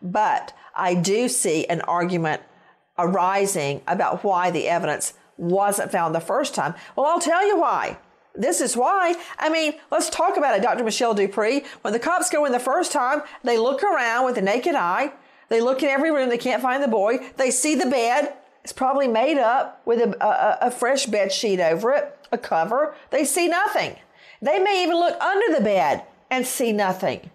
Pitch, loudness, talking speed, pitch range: 255 Hz, -21 LUFS, 195 wpm, 200-295 Hz